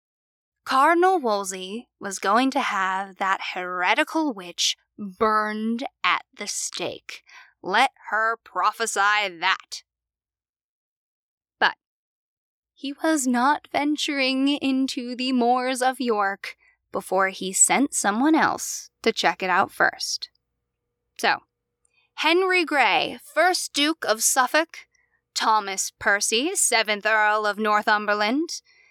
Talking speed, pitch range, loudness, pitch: 105 wpm, 210-300 Hz, -22 LUFS, 245 Hz